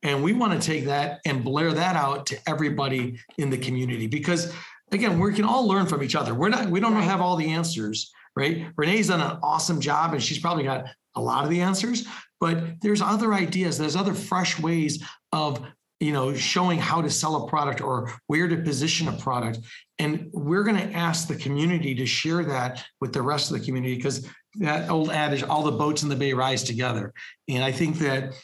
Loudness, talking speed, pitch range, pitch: -25 LUFS, 215 wpm, 135-175 Hz, 155 Hz